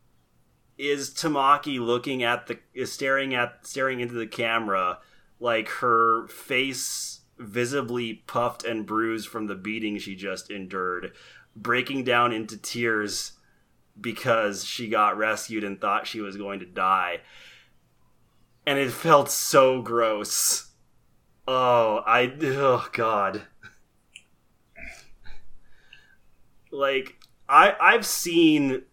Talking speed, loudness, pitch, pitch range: 110 wpm, -24 LUFS, 120 Hz, 110-130 Hz